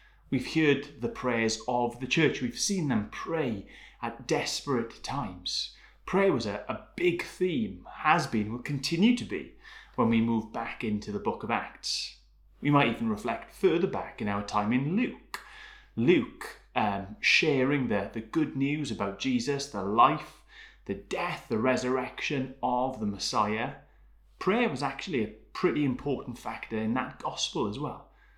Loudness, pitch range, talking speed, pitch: -29 LUFS, 110-150 Hz, 160 wpm, 130 Hz